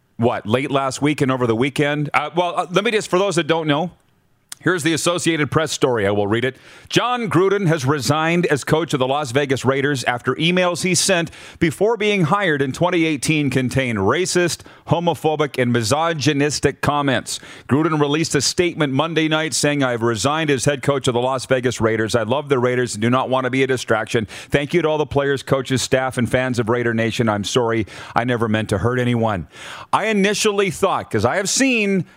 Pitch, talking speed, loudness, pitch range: 145 Hz, 205 wpm, -19 LUFS, 125-165 Hz